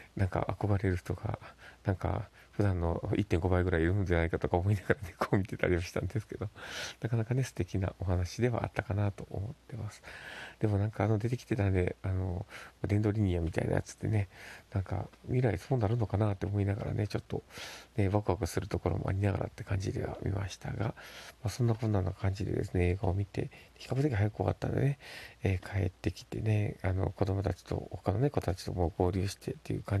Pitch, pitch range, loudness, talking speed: 100 Hz, 95-110 Hz, -33 LUFS, 430 characters per minute